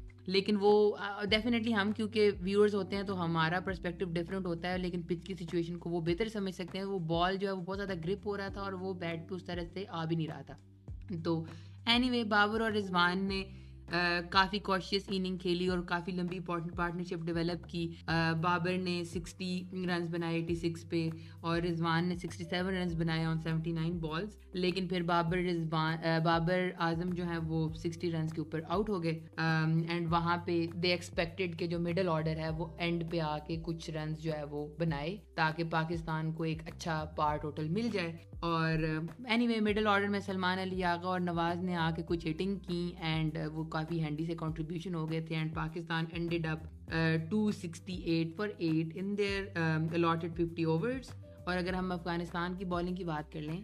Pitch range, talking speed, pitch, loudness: 165-185 Hz, 190 wpm, 175 Hz, -34 LUFS